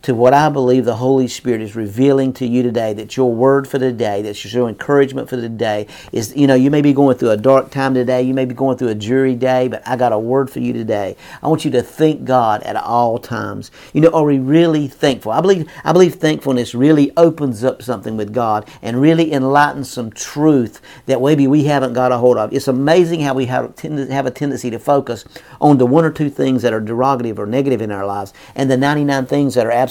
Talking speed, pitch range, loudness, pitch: 245 wpm, 120-140 Hz, -15 LUFS, 130 Hz